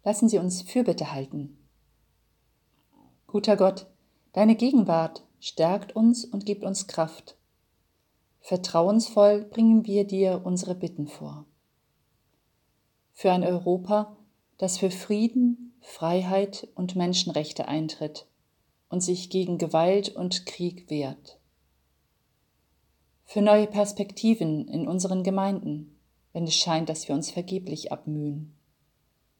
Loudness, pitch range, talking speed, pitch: -26 LUFS, 150-205 Hz, 110 wpm, 180 Hz